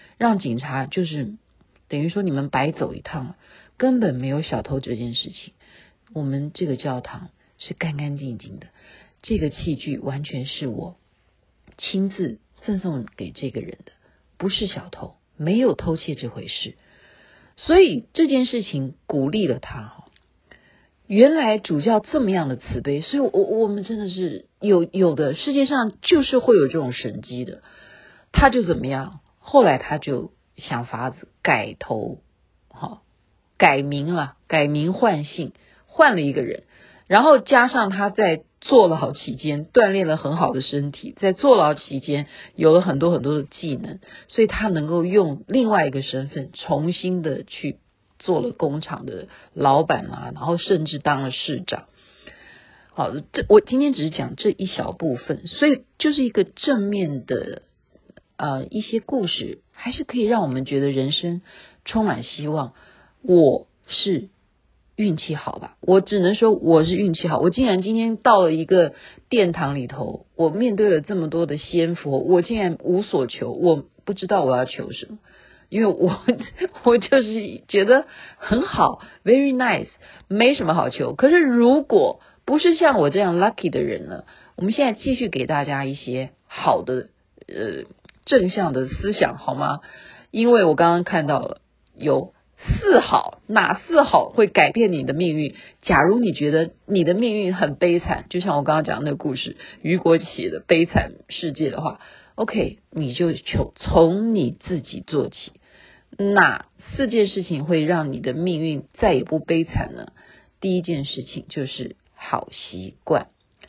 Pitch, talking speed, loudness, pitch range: 175 Hz, 235 characters per minute, -20 LUFS, 145-215 Hz